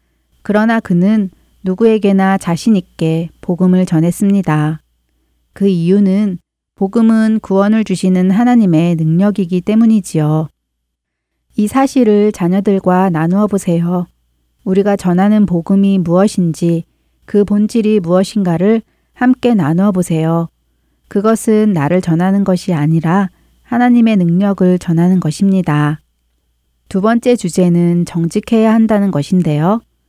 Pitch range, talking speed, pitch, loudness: 165-210 Hz, 270 characters per minute, 185 Hz, -13 LUFS